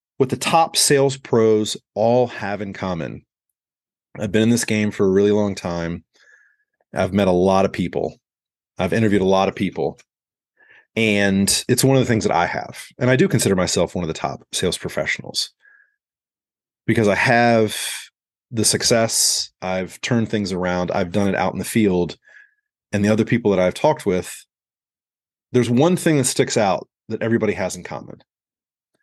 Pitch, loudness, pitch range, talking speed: 105 Hz, -19 LUFS, 95-120 Hz, 180 wpm